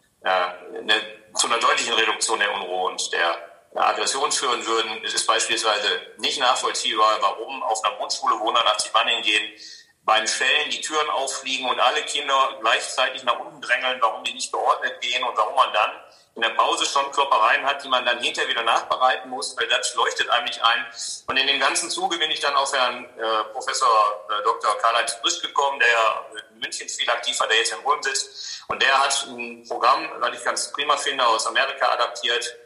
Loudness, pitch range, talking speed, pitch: -21 LUFS, 110-135 Hz, 190 wpm, 120 Hz